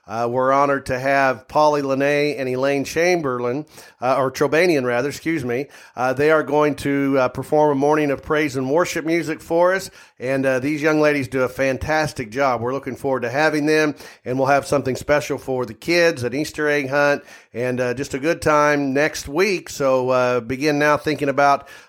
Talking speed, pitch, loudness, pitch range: 200 wpm, 140 Hz, -19 LUFS, 130-150 Hz